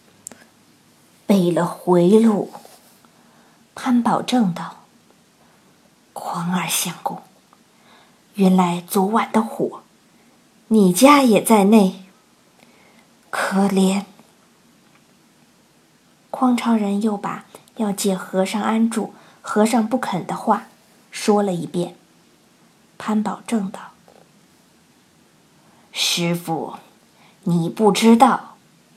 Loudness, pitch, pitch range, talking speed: -19 LUFS, 205 Hz, 185-220 Hz, 115 characters per minute